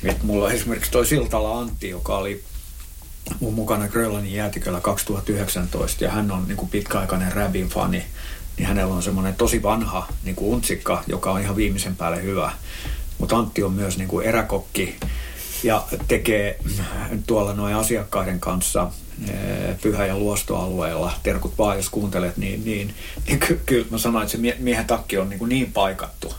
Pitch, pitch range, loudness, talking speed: 100 Hz, 95-110 Hz, -23 LUFS, 160 wpm